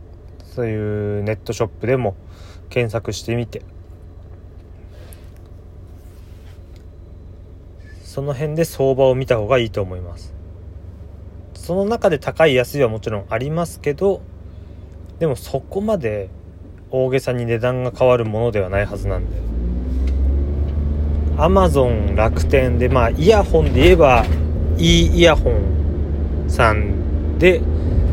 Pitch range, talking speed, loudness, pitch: 85-115 Hz, 230 characters per minute, -18 LUFS, 90 Hz